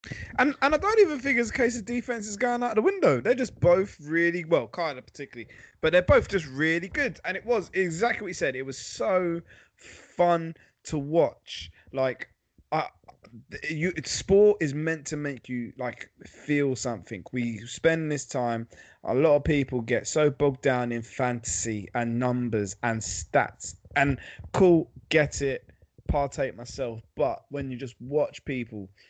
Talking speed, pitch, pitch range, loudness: 175 wpm, 145 Hz, 120-180 Hz, -26 LUFS